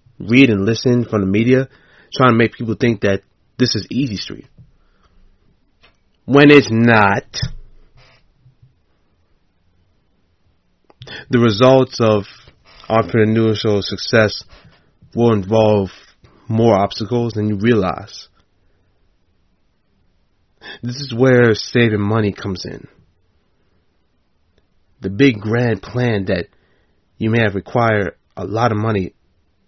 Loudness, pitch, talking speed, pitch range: -15 LUFS, 105 Hz, 105 wpm, 95-120 Hz